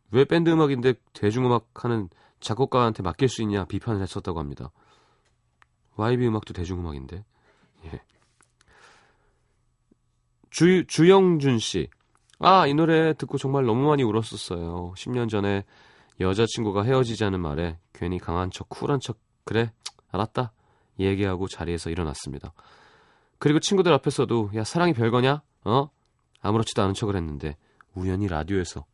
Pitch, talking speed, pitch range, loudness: 110 Hz, 305 characters per minute, 95-130 Hz, -24 LUFS